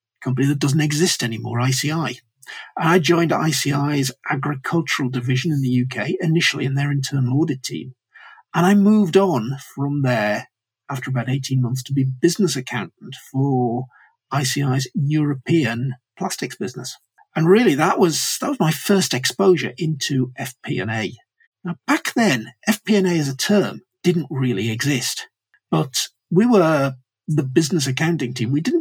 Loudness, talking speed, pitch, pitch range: -20 LUFS, 150 wpm, 145 Hz, 130-170 Hz